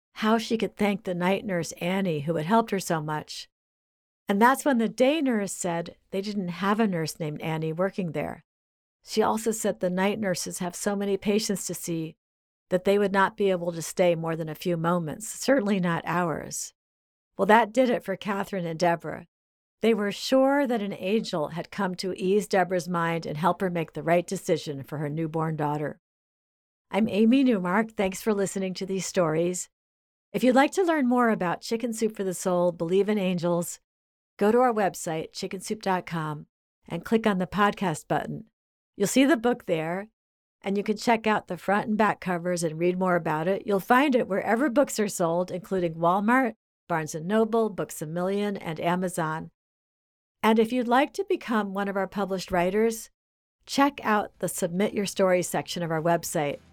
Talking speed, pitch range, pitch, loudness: 195 wpm, 170-215 Hz, 190 Hz, -26 LUFS